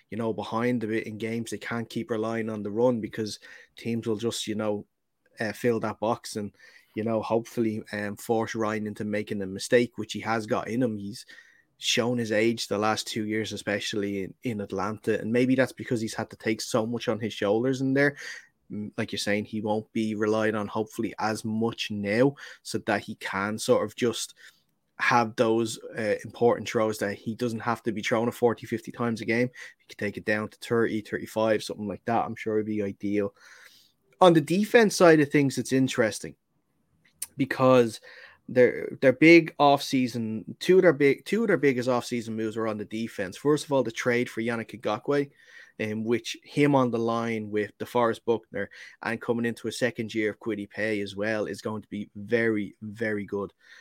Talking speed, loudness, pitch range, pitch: 205 wpm, -27 LUFS, 105-120 Hz, 110 Hz